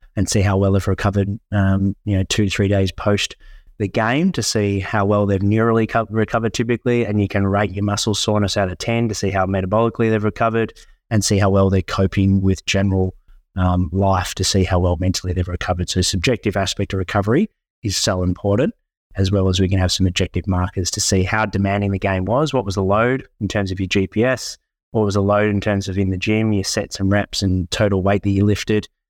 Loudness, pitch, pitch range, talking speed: -19 LUFS, 100 Hz, 95-105 Hz, 225 wpm